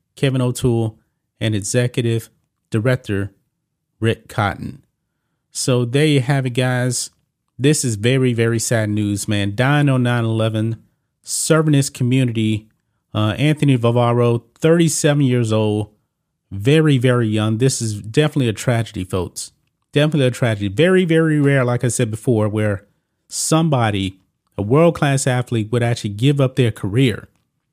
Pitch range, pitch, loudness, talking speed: 110-140 Hz, 125 Hz, -18 LUFS, 135 wpm